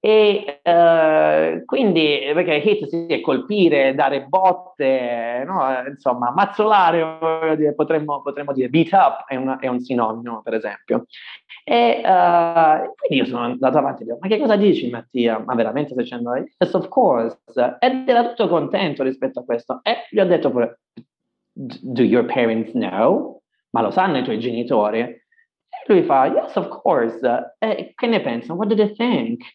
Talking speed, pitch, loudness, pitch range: 175 wpm, 150 Hz, -19 LUFS, 125-190 Hz